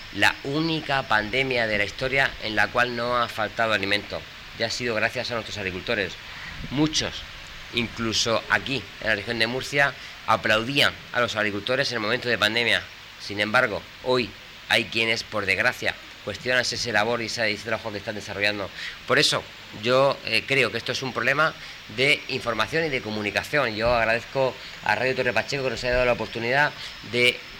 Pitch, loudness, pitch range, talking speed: 115 Hz, -24 LUFS, 105-125 Hz, 175 wpm